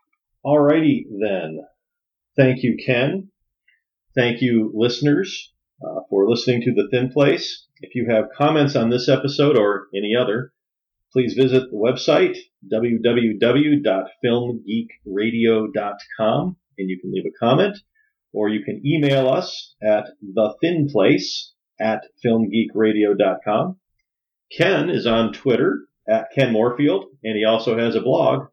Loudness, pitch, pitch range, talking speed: -19 LUFS, 120 Hz, 110-145 Hz, 125 wpm